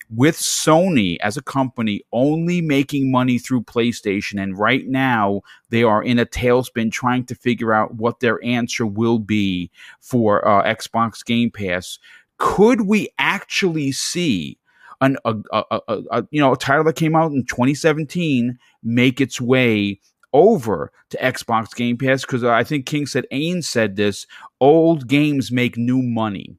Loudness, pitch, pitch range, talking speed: -18 LUFS, 125 Hz, 115-140 Hz, 160 wpm